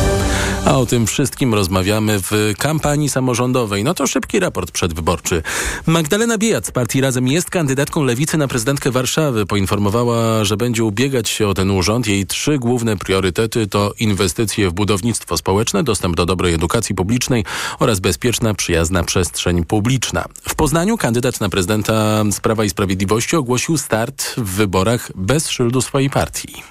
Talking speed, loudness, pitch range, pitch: 150 wpm, -17 LUFS, 100-130 Hz, 115 Hz